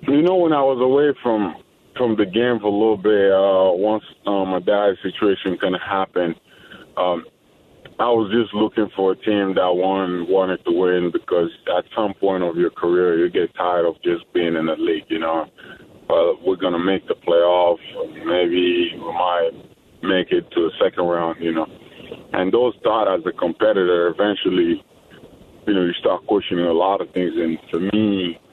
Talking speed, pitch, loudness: 190 wpm, 110 Hz, -19 LUFS